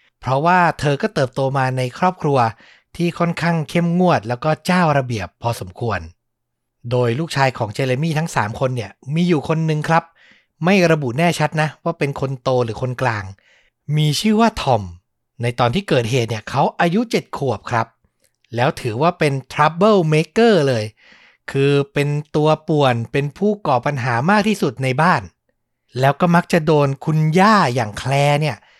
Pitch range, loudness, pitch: 125-170 Hz, -18 LUFS, 145 Hz